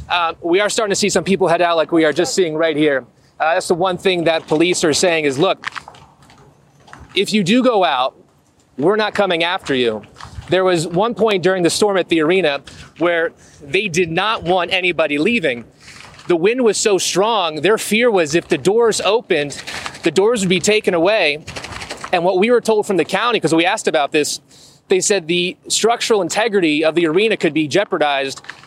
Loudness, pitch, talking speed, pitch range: -16 LUFS, 185 Hz, 205 wpm, 165-215 Hz